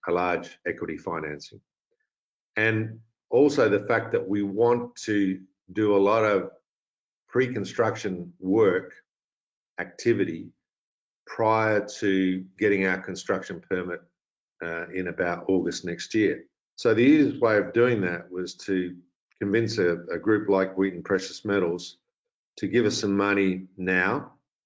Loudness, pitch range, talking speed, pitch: -25 LUFS, 90-110 Hz, 135 wpm, 95 Hz